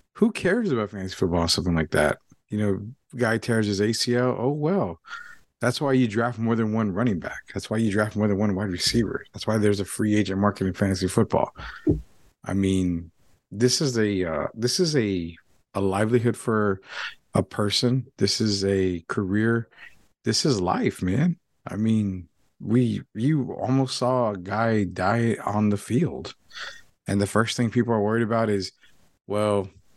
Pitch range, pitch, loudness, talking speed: 100-120 Hz, 105 Hz, -24 LUFS, 180 wpm